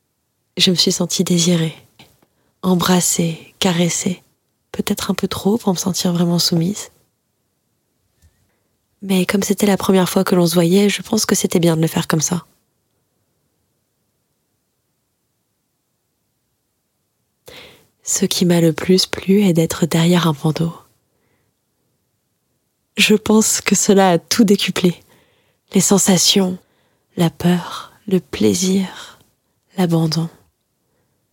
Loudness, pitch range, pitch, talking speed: -16 LUFS, 165-195 Hz, 180 Hz, 115 wpm